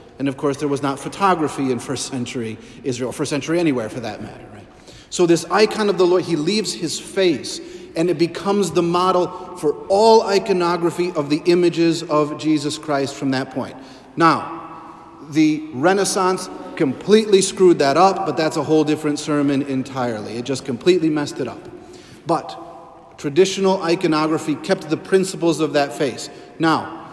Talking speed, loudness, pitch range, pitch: 170 wpm, -19 LUFS, 145-180 Hz, 160 Hz